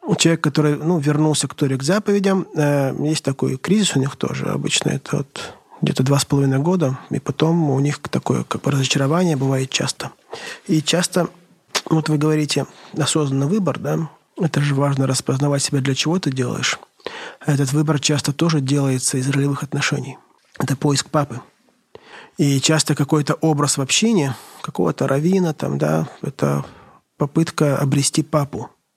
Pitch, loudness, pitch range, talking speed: 145 Hz, -19 LUFS, 140-160 Hz, 150 wpm